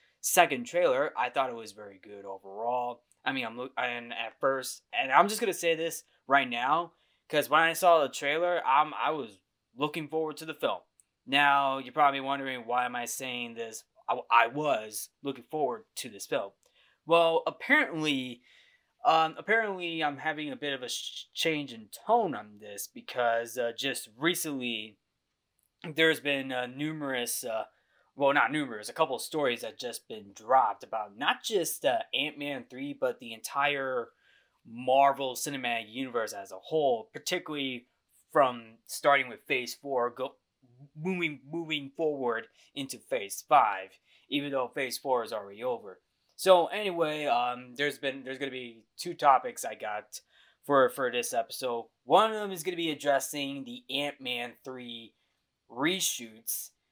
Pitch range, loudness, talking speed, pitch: 120-160 Hz, -30 LUFS, 160 wpm, 140 Hz